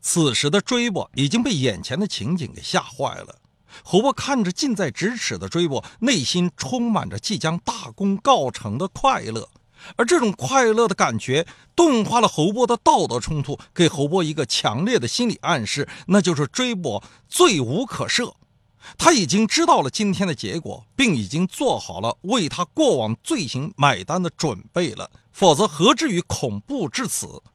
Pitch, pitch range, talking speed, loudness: 185 Hz, 150-235 Hz, 260 characters per minute, -21 LUFS